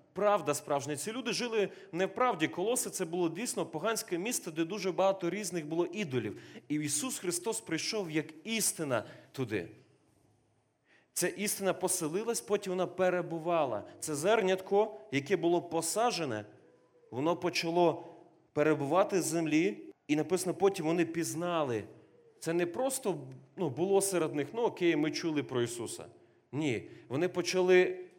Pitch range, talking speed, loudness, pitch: 160-195 Hz, 135 wpm, -32 LUFS, 175 Hz